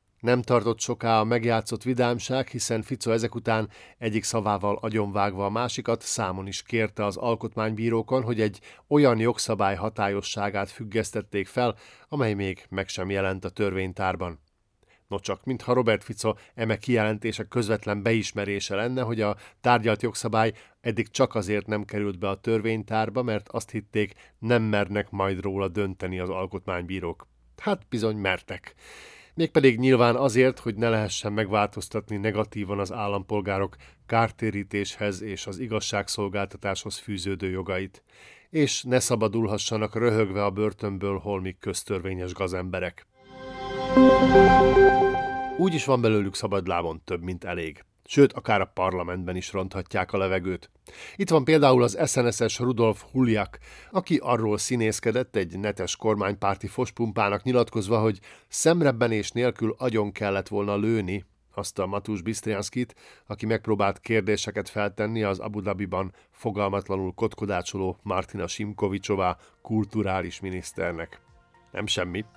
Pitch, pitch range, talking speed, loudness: 105 Hz, 100-120 Hz, 125 wpm, -26 LUFS